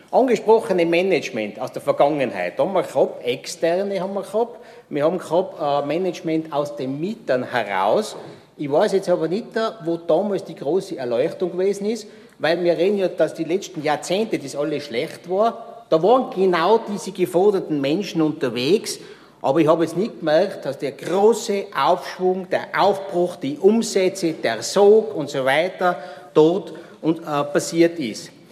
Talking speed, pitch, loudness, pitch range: 160 wpm, 180 Hz, -21 LUFS, 160-205 Hz